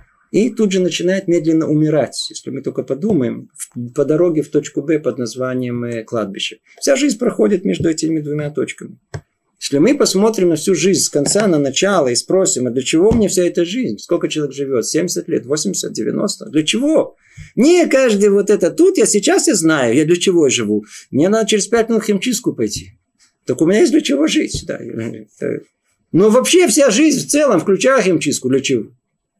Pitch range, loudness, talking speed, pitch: 150-230 Hz, -15 LUFS, 185 wpm, 180 Hz